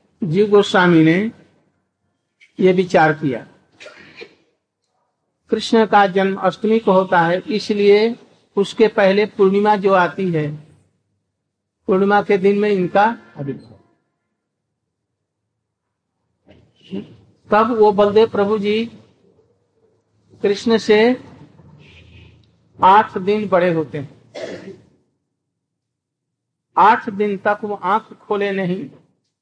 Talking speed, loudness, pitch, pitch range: 90 wpm, -16 LUFS, 200 Hz, 175-210 Hz